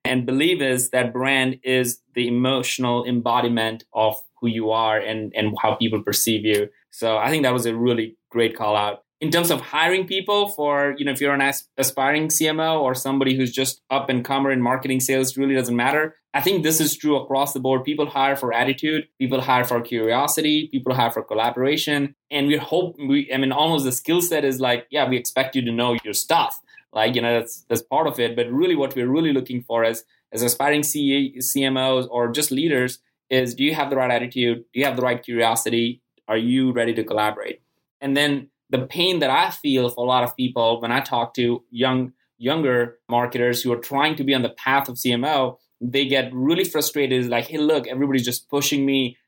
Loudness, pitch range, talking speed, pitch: -21 LUFS, 120-140 Hz, 215 wpm, 130 Hz